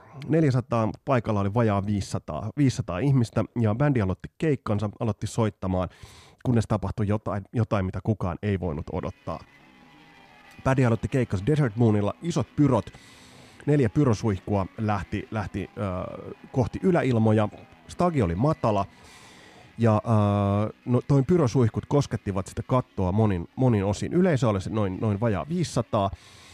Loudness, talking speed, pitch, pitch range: -26 LUFS, 130 wpm, 110 Hz, 100-130 Hz